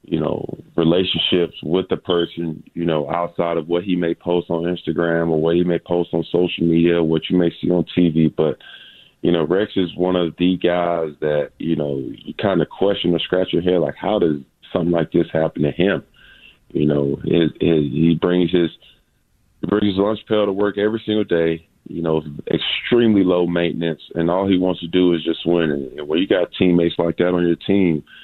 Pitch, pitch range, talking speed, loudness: 85 Hz, 80-90 Hz, 210 wpm, -19 LUFS